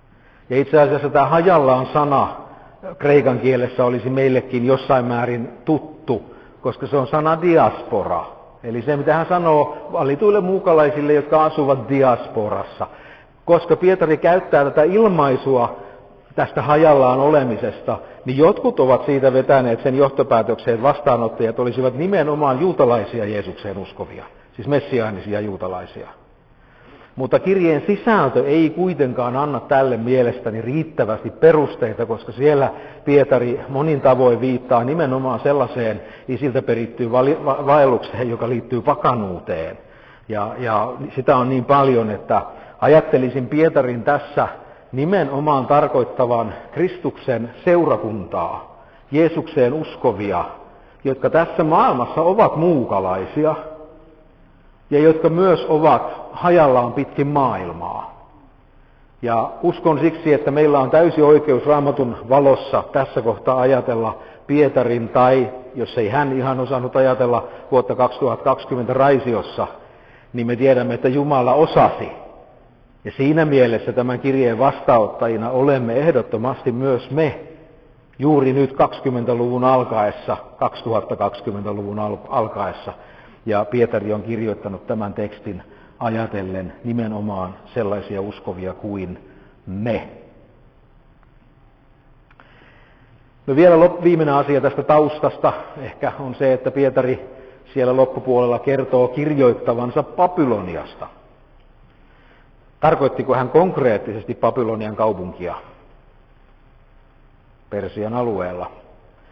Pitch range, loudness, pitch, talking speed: 120-150 Hz, -18 LUFS, 130 Hz, 105 wpm